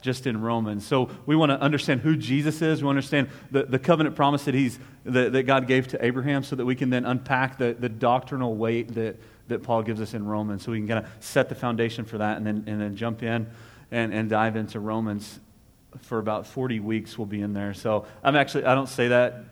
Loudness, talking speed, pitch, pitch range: -25 LUFS, 245 wpm, 120 Hz, 110-135 Hz